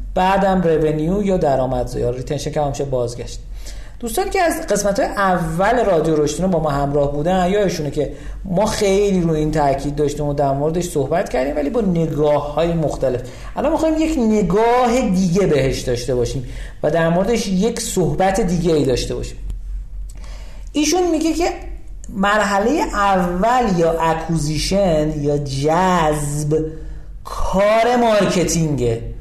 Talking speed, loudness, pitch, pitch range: 140 wpm, -18 LUFS, 165 Hz, 145-205 Hz